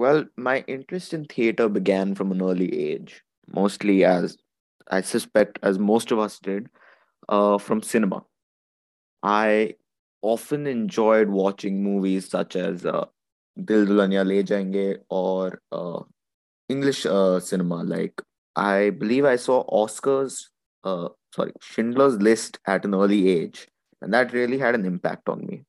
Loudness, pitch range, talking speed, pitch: -23 LUFS, 95-115 Hz, 140 wpm, 100 Hz